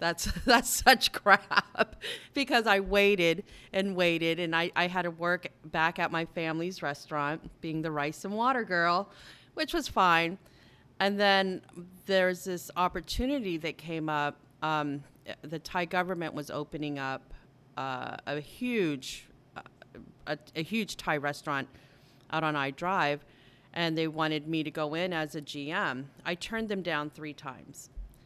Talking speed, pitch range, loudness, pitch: 155 wpm, 145-180 Hz, -30 LUFS, 160 Hz